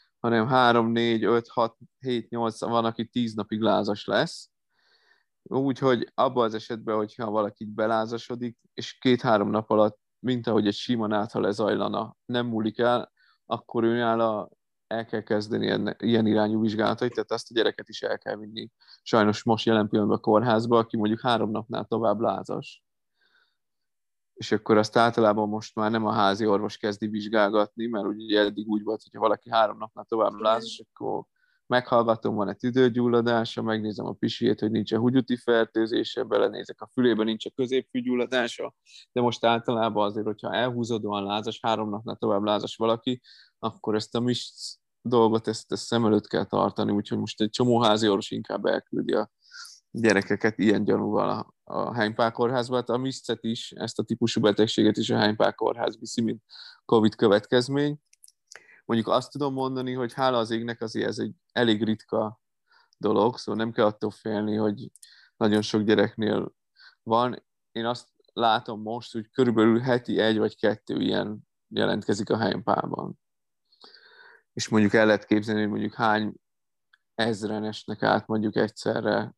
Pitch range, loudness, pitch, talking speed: 105-120 Hz, -26 LUFS, 110 Hz, 155 wpm